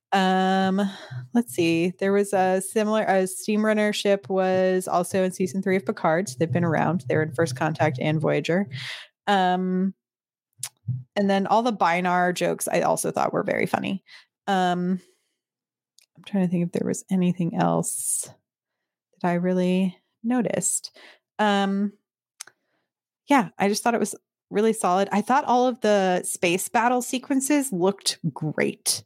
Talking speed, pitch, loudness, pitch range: 155 wpm, 190 Hz, -24 LUFS, 175-205 Hz